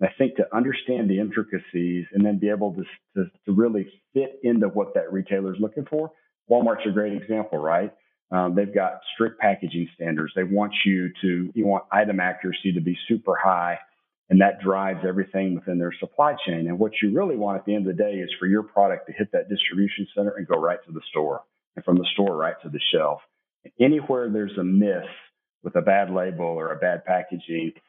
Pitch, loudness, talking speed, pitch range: 100 Hz, -24 LUFS, 215 wpm, 90-105 Hz